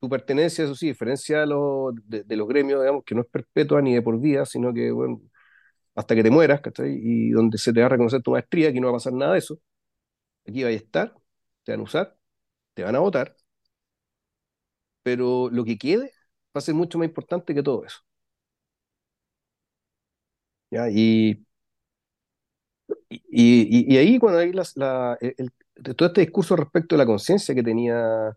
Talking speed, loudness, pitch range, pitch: 190 wpm, -21 LUFS, 115-155 Hz, 130 Hz